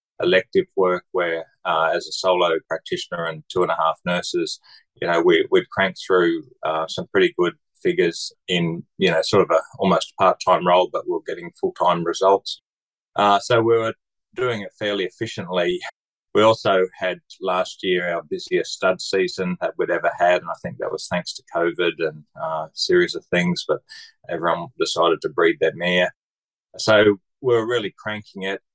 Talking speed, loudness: 190 wpm, -21 LUFS